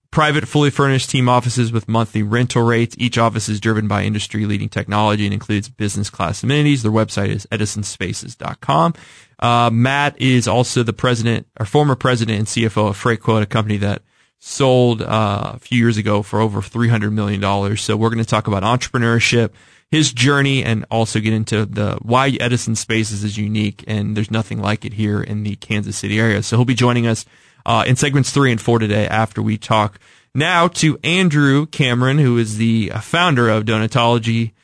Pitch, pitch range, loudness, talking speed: 115 Hz, 105-125 Hz, -17 LUFS, 185 wpm